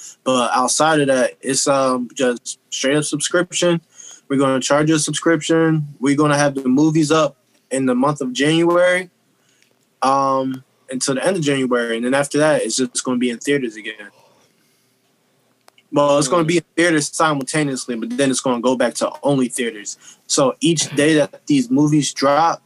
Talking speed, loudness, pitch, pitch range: 175 wpm, -17 LUFS, 145 Hz, 130-155 Hz